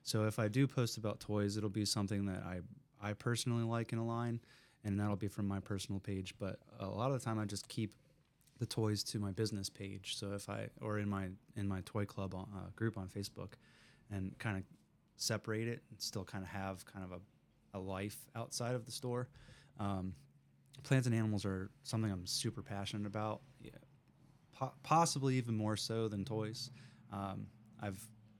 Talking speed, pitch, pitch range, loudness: 200 wpm, 110 Hz, 100-120 Hz, -41 LUFS